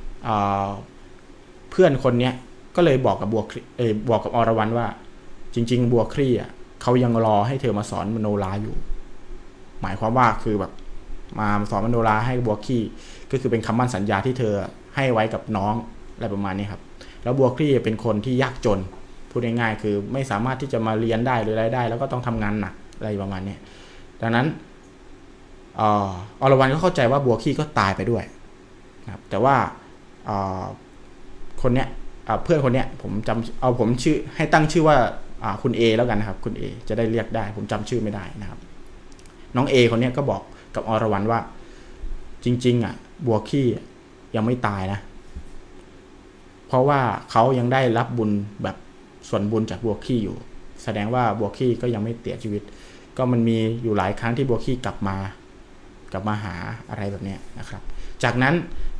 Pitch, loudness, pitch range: 115 Hz, -23 LUFS, 100-125 Hz